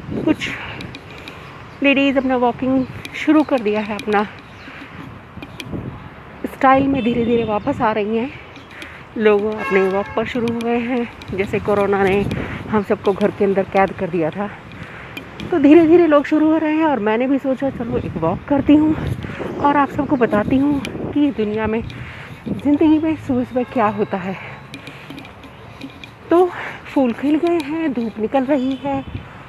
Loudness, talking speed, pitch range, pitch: -18 LUFS, 160 wpm, 210-285 Hz, 245 Hz